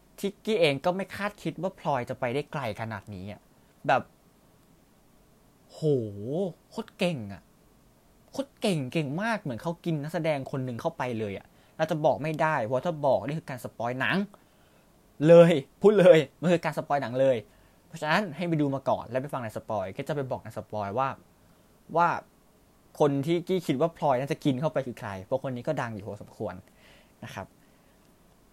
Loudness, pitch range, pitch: -27 LUFS, 125-170 Hz, 145 Hz